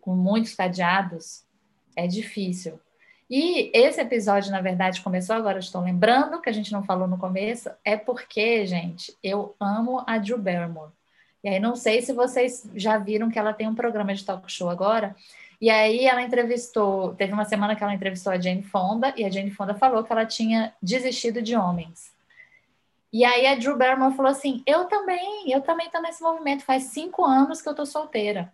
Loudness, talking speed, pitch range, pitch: -24 LUFS, 190 wpm, 195-255 Hz, 220 Hz